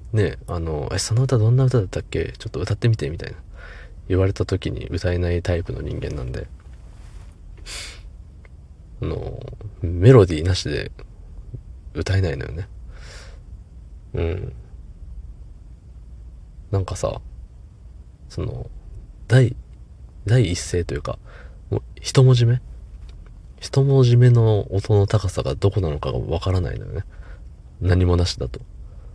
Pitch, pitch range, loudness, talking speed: 90 Hz, 80-110 Hz, -21 LUFS, 240 characters per minute